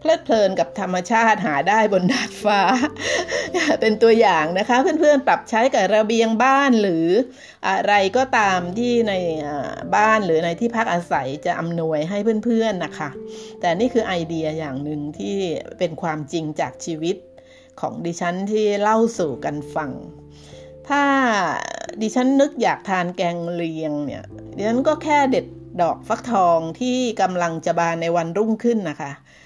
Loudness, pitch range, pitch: -20 LUFS, 165-235 Hz, 195 Hz